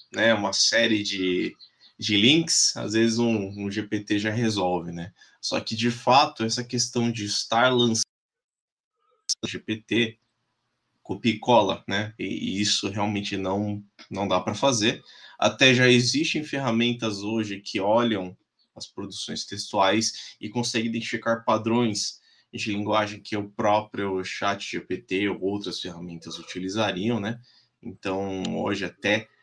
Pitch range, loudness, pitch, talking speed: 100-120 Hz, -24 LUFS, 110 Hz, 135 wpm